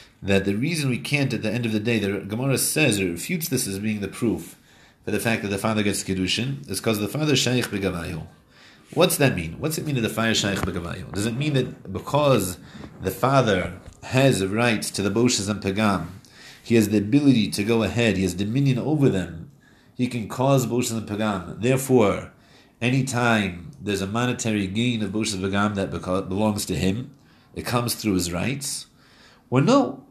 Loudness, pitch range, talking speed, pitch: -23 LUFS, 95-125 Hz, 200 wpm, 110 Hz